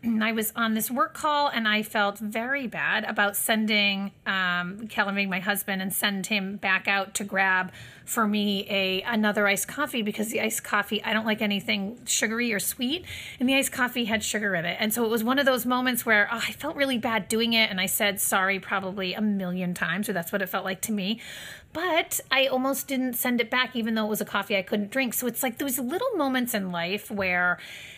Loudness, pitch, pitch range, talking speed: -25 LUFS, 215 Hz, 200-240 Hz, 230 wpm